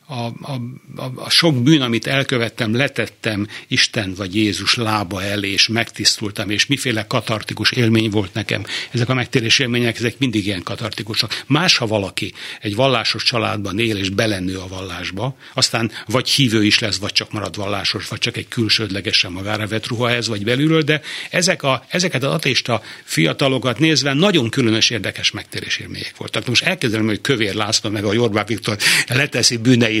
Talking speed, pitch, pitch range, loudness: 170 wpm, 115 Hz, 105-130 Hz, -17 LUFS